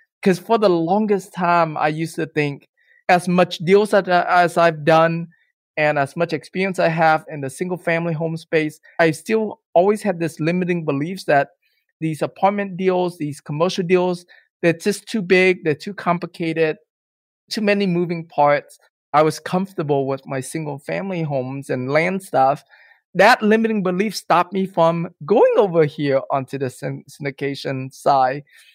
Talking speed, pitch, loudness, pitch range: 160 wpm, 170 Hz, -19 LUFS, 150-185 Hz